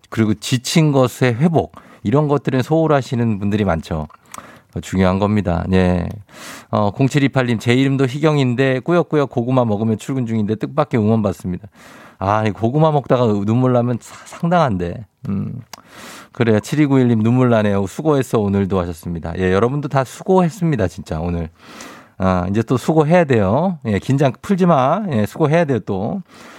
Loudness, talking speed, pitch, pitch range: -17 LUFS, 320 characters per minute, 120 Hz, 100-145 Hz